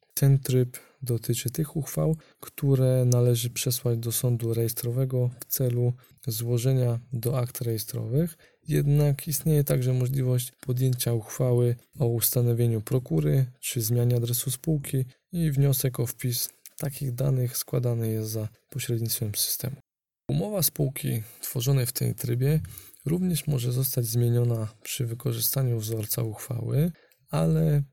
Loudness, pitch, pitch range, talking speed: -27 LUFS, 125 Hz, 120-140 Hz, 120 wpm